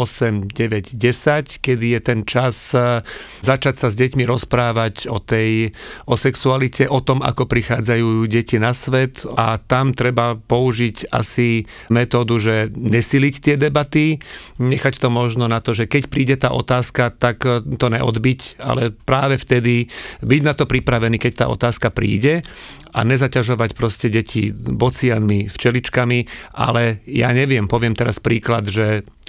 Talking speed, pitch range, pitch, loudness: 145 wpm, 115-130 Hz, 120 Hz, -18 LUFS